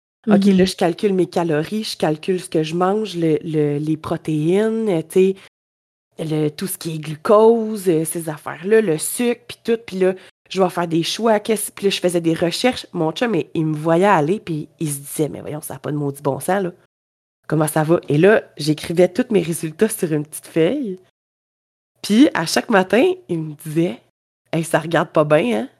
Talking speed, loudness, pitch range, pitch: 205 wpm, -19 LUFS, 155-195 Hz, 170 Hz